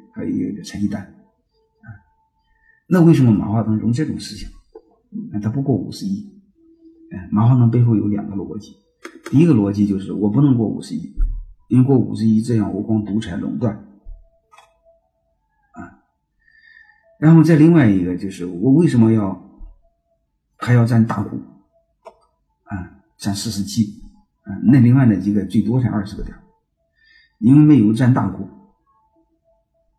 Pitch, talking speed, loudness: 125 Hz, 220 characters per minute, -17 LUFS